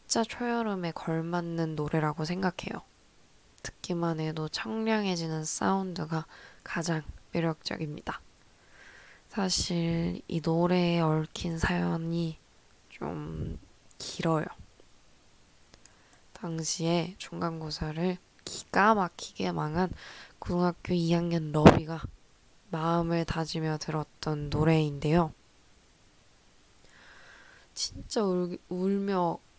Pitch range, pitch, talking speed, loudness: 155-180 Hz, 165 Hz, 195 characters per minute, -30 LUFS